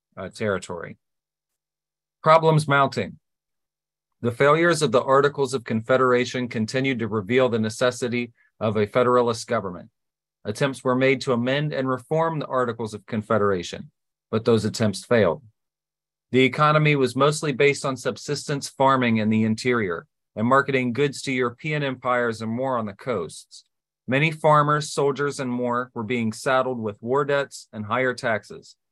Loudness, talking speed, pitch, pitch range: -22 LUFS, 145 wpm, 125 Hz, 115-140 Hz